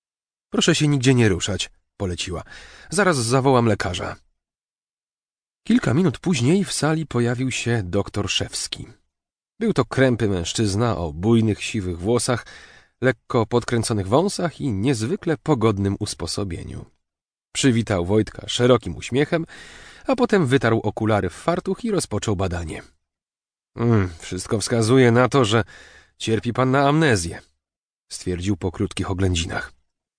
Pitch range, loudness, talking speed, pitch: 100-135 Hz, -21 LUFS, 120 wpm, 115 Hz